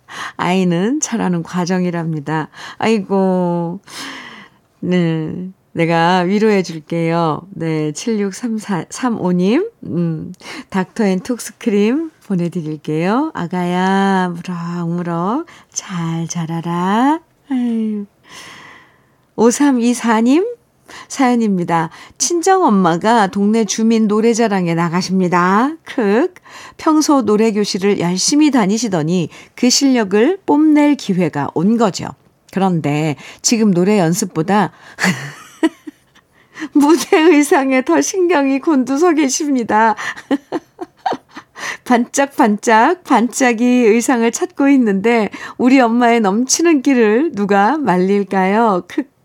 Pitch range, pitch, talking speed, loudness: 180-265 Hz, 215 Hz, 205 characters per minute, -15 LUFS